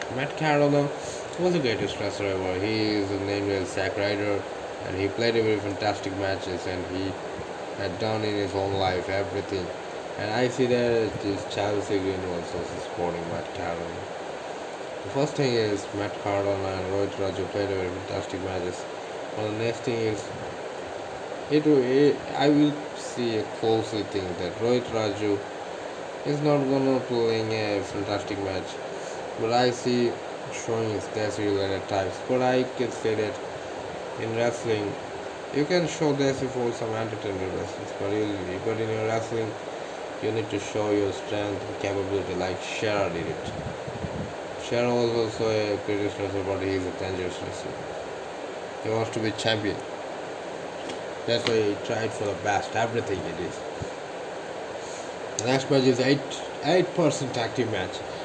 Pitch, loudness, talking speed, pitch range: 105 Hz, -28 LUFS, 160 wpm, 100-120 Hz